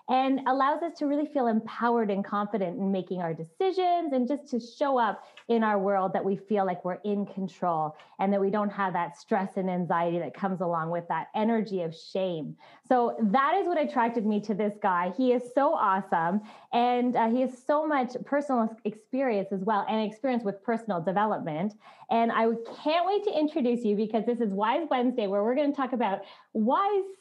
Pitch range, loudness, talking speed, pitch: 195-260 Hz, -28 LUFS, 205 wpm, 220 Hz